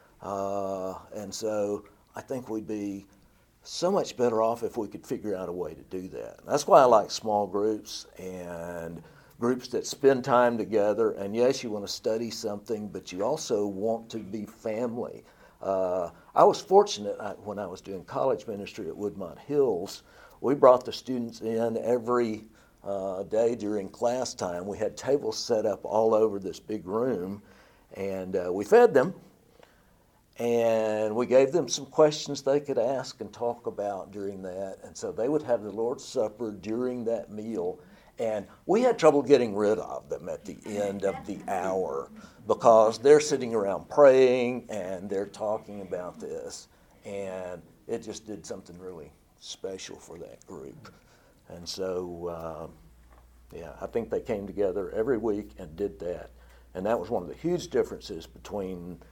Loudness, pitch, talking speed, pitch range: -28 LUFS, 105 Hz, 170 wpm, 95-120 Hz